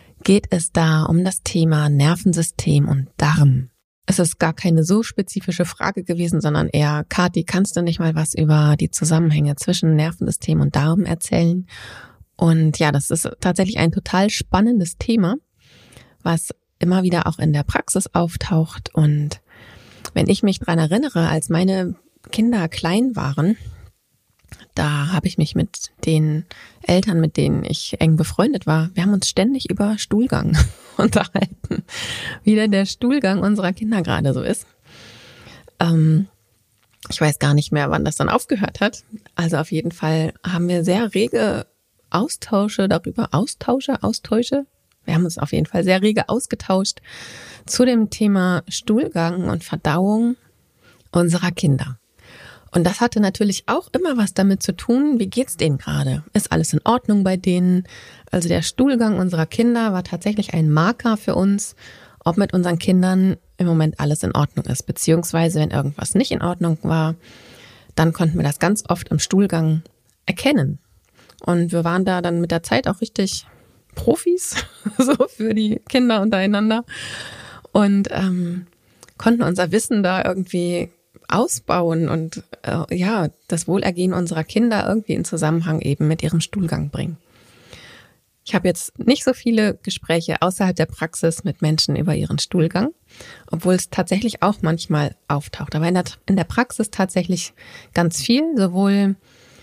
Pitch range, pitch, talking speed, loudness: 160-200 Hz, 175 Hz, 155 wpm, -19 LUFS